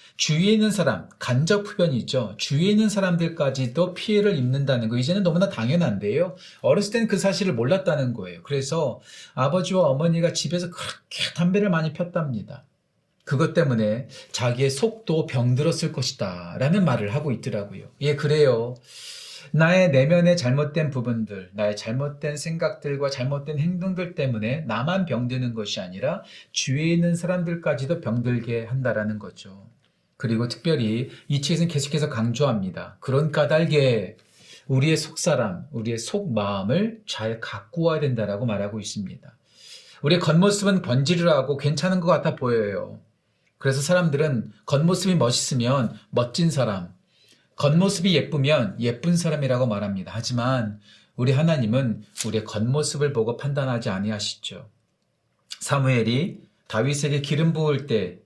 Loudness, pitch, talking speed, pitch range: -23 LUFS, 145 Hz, 340 characters per minute, 120-170 Hz